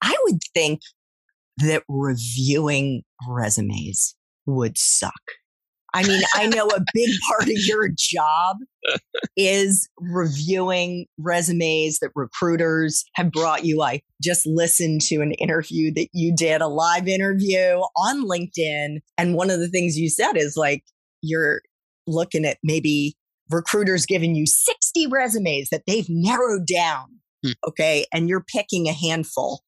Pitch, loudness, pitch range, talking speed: 170 Hz, -21 LUFS, 155-190 Hz, 135 wpm